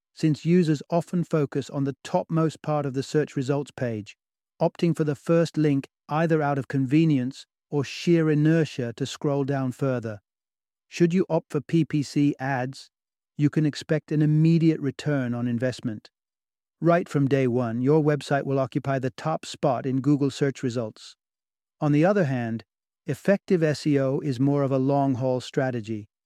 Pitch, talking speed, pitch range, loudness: 140 Hz, 160 wpm, 130-155 Hz, -25 LUFS